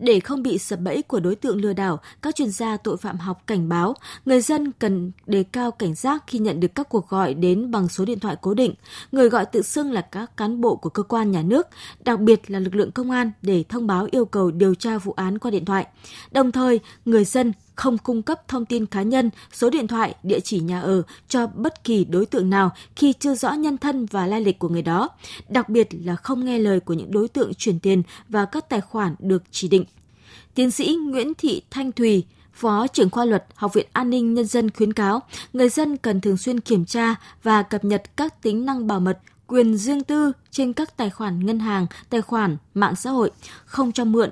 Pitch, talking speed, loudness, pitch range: 220 Hz, 235 wpm, -22 LUFS, 195-250 Hz